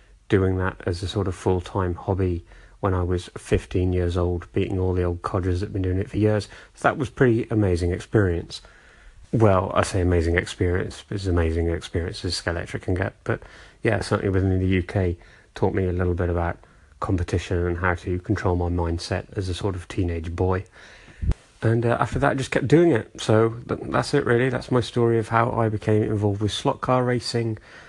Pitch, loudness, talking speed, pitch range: 95 Hz, -24 LUFS, 200 wpm, 90-110 Hz